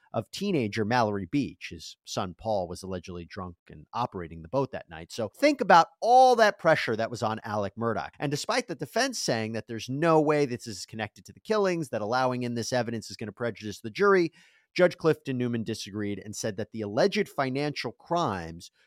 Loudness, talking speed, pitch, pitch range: -27 LUFS, 205 wpm, 120 Hz, 105-160 Hz